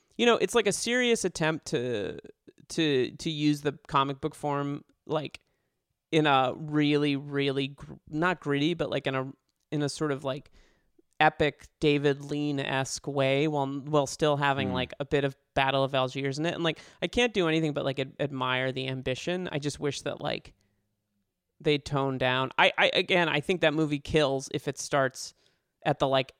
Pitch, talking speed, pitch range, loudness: 145 Hz, 190 wpm, 135-155 Hz, -28 LUFS